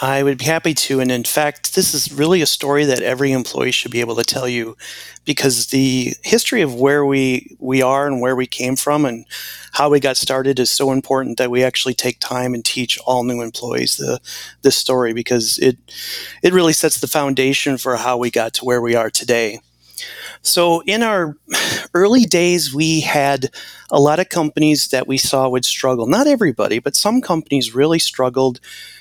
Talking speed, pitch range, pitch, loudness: 195 wpm, 125-150 Hz, 135 Hz, -16 LUFS